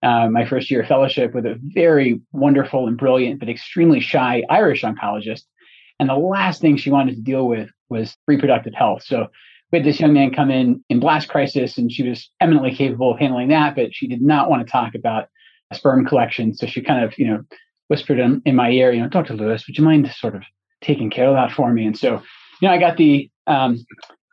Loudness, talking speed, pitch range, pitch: -17 LUFS, 230 wpm, 120-150 Hz, 135 Hz